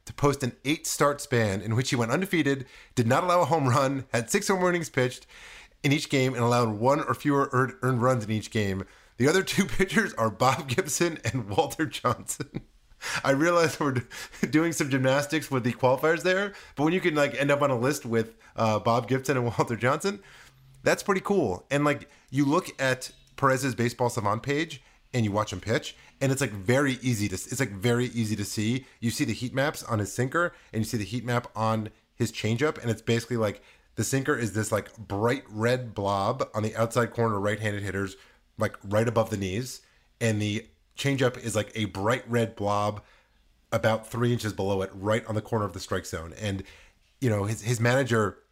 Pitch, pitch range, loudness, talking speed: 120 Hz, 110-140 Hz, -27 LUFS, 210 wpm